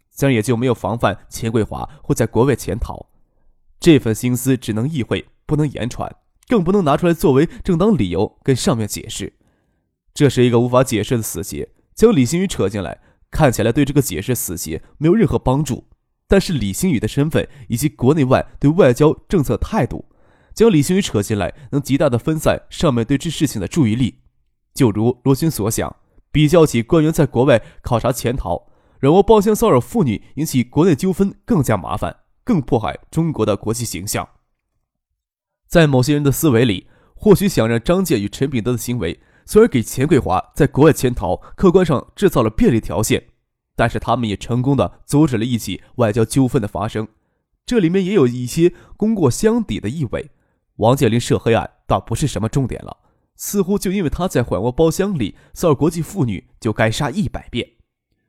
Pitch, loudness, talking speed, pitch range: 125 Hz, -17 LUFS, 290 characters per minute, 110-155 Hz